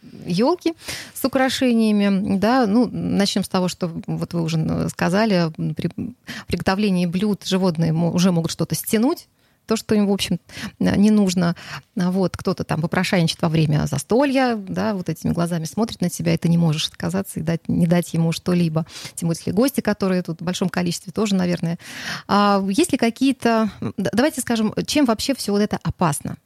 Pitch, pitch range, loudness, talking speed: 190 Hz, 170-220 Hz, -21 LUFS, 170 wpm